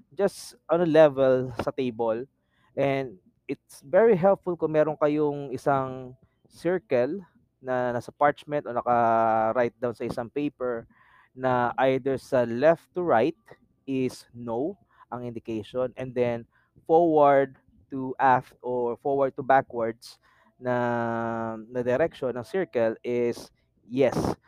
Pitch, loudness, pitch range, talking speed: 130 Hz, -26 LUFS, 120-145 Hz, 125 wpm